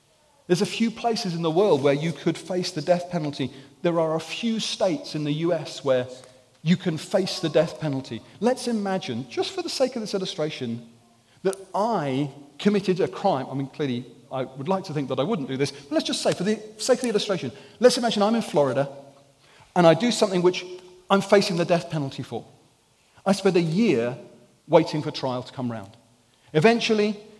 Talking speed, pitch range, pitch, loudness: 205 wpm, 135-200 Hz, 170 Hz, -24 LUFS